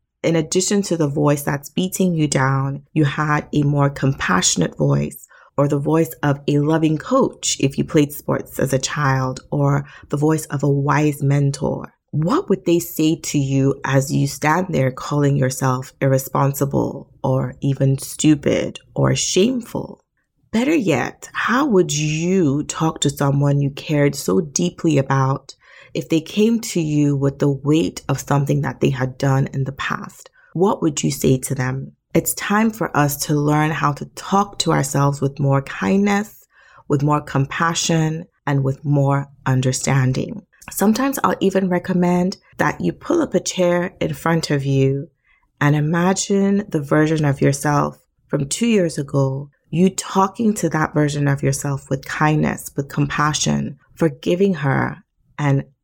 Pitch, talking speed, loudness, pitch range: 145 Hz, 160 wpm, -19 LUFS, 135-165 Hz